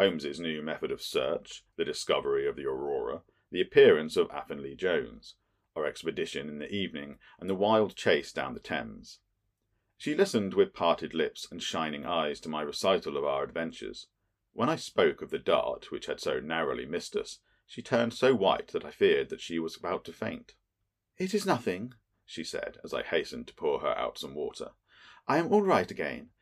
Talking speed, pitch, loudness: 195 wpm, 385 Hz, -30 LUFS